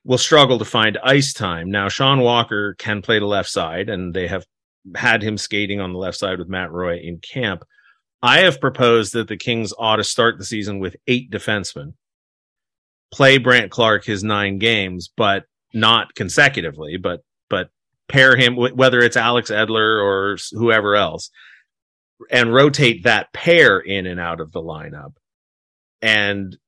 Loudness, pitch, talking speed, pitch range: -16 LUFS, 110 Hz, 165 wpm, 95-120 Hz